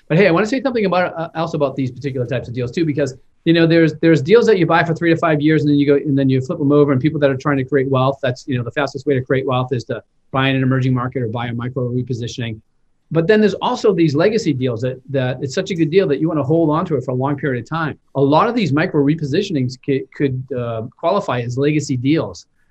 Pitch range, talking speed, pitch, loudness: 130-160 Hz, 295 wpm, 140 Hz, -17 LUFS